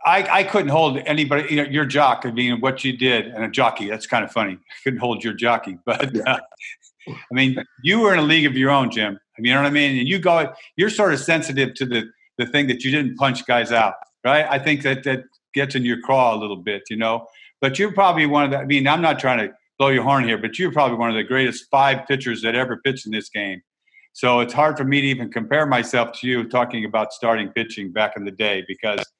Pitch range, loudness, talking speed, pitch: 115-145 Hz, -19 LUFS, 265 wpm, 130 Hz